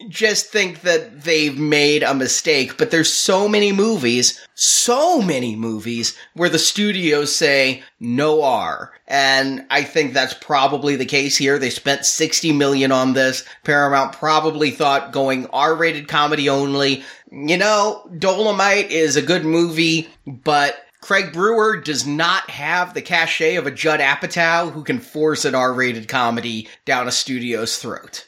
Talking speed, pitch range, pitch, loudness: 150 wpm, 135-175 Hz, 150 Hz, -17 LUFS